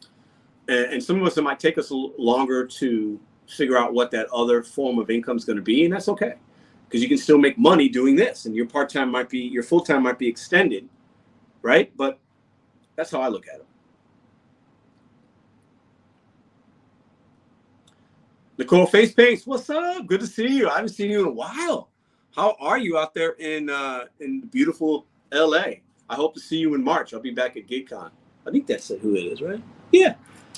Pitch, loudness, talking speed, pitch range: 145 Hz, -22 LUFS, 195 wpm, 125-205 Hz